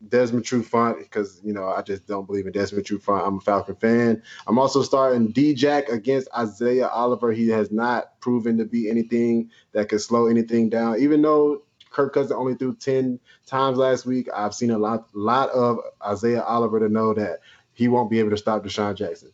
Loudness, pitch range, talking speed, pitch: -22 LUFS, 105-125 Hz, 210 wpm, 115 Hz